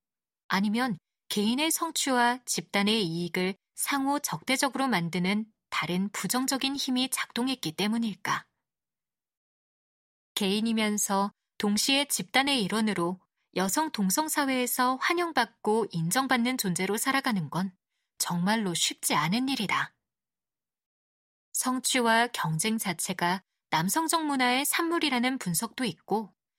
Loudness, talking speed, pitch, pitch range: -28 LUFS, 255 characters per minute, 220 Hz, 190-260 Hz